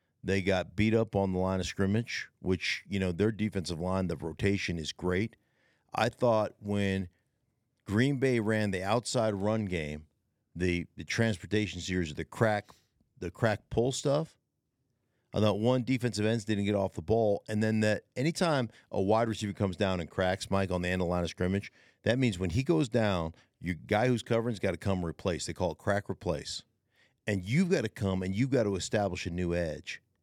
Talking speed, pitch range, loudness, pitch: 200 wpm, 90-115 Hz, -31 LUFS, 100 Hz